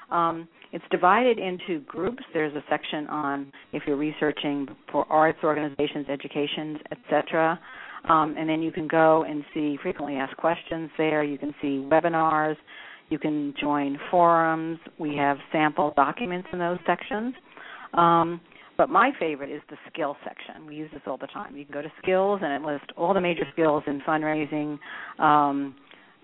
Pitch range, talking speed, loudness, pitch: 145-165 Hz, 170 wpm, -25 LUFS, 155 Hz